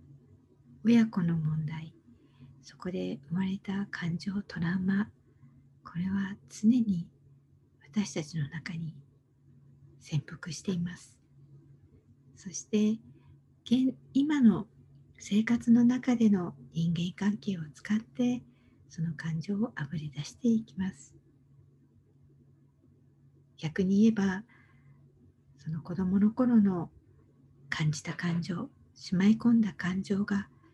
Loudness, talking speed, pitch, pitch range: -30 LUFS, 190 characters per minute, 165 Hz, 135-200 Hz